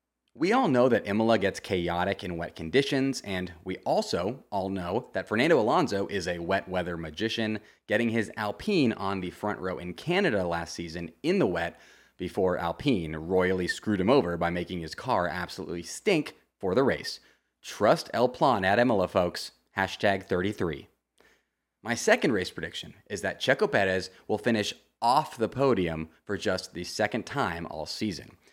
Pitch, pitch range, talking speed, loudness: 95 Hz, 85-110 Hz, 170 wpm, -28 LUFS